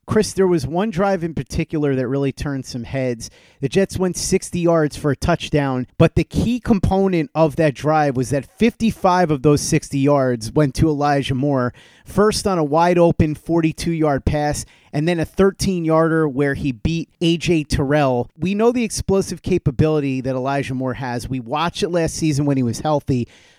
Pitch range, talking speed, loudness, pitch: 140-170 Hz, 190 wpm, -19 LUFS, 155 Hz